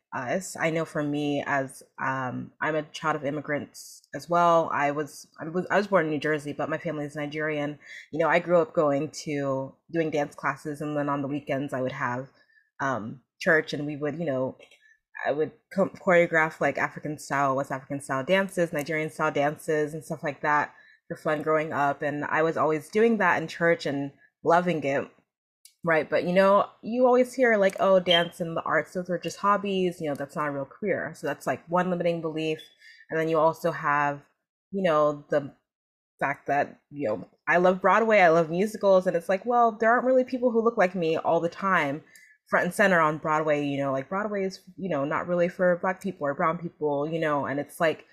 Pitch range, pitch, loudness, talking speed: 145-180 Hz, 160 Hz, -26 LUFS, 215 wpm